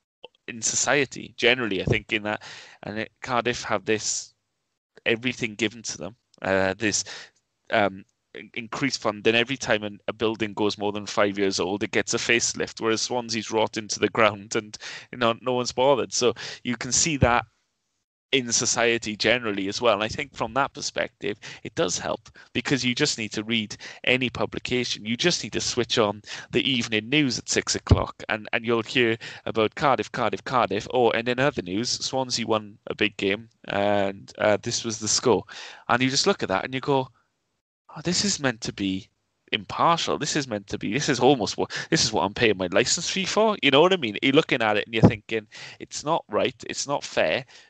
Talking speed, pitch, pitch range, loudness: 205 wpm, 115 Hz, 105-125 Hz, -24 LUFS